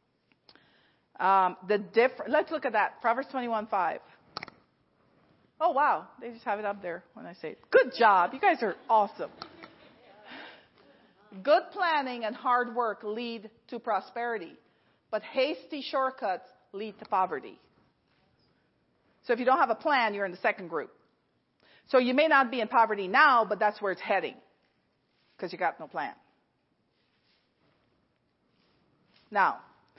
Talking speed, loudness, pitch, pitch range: 145 wpm, -28 LUFS, 230 Hz, 210-265 Hz